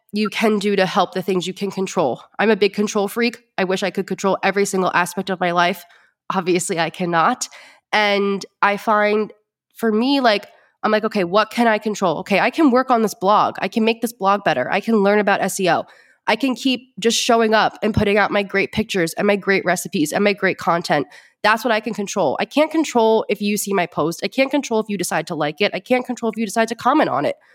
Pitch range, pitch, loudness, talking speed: 190-225 Hz, 205 Hz, -19 LUFS, 245 wpm